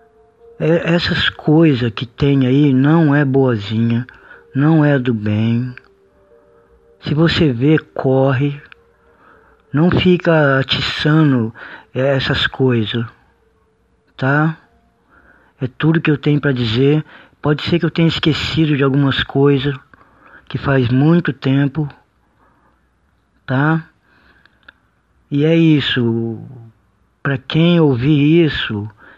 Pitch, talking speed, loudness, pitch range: 140 Hz, 105 wpm, -15 LUFS, 125-155 Hz